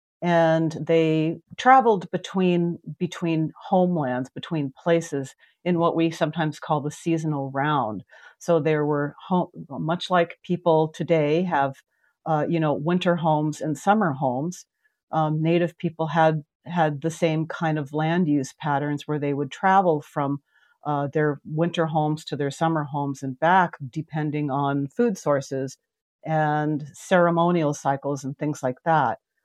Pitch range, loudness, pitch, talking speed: 145-170 Hz, -24 LUFS, 155 Hz, 145 wpm